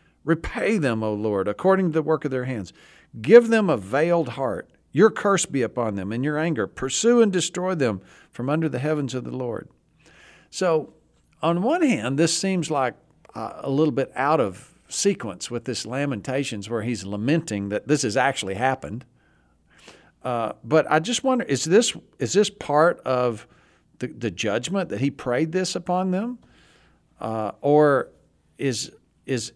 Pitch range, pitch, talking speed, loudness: 125-180 Hz, 145 Hz, 170 wpm, -23 LUFS